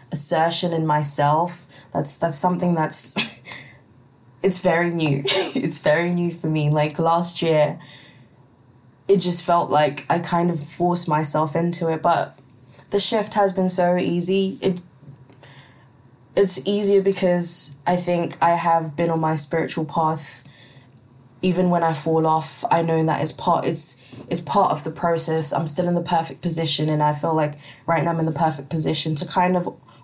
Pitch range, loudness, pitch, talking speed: 145-175 Hz, -20 LUFS, 160 Hz, 170 wpm